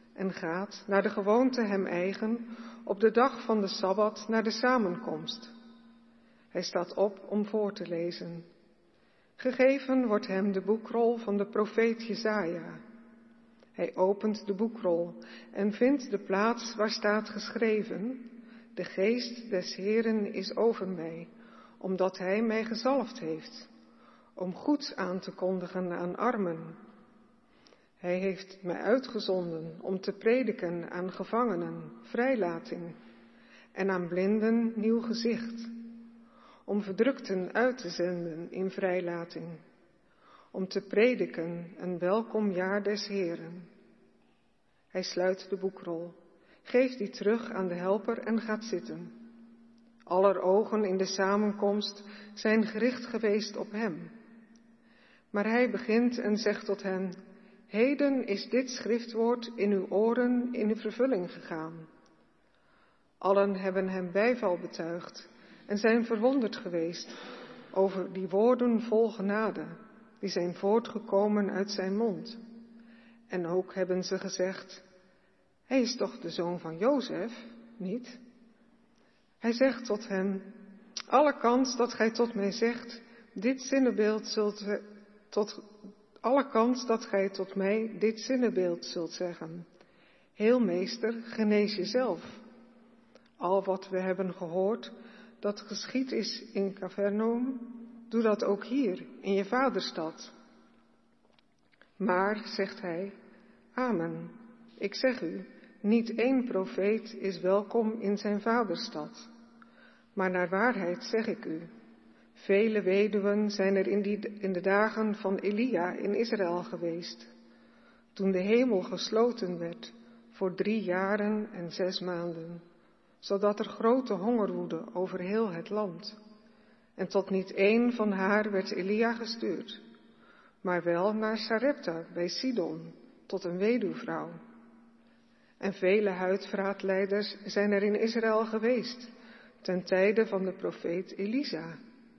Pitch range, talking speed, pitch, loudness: 190-230 Hz, 125 wpm, 210 Hz, -31 LUFS